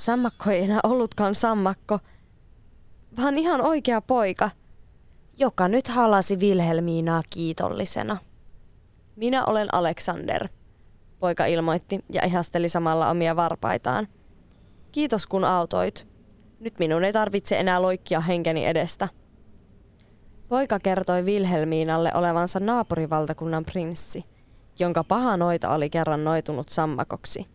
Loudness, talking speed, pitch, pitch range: -24 LUFS, 105 wpm, 175 Hz, 160-205 Hz